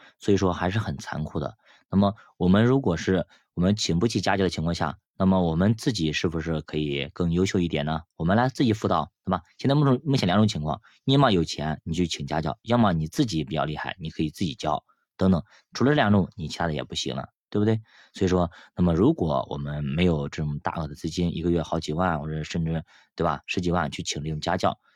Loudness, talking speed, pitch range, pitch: -25 LUFS, 345 characters per minute, 80-95 Hz, 85 Hz